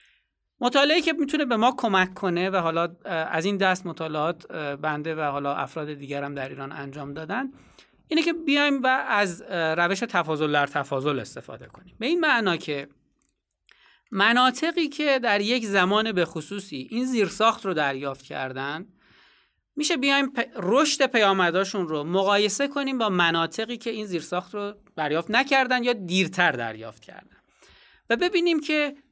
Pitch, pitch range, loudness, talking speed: 195 Hz, 160-255 Hz, -24 LUFS, 150 wpm